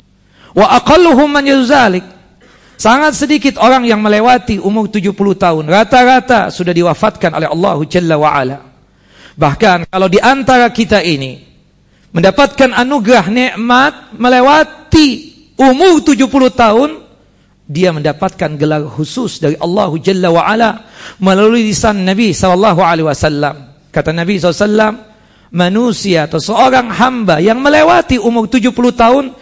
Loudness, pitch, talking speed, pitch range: -10 LUFS, 215 Hz, 110 wpm, 180-255 Hz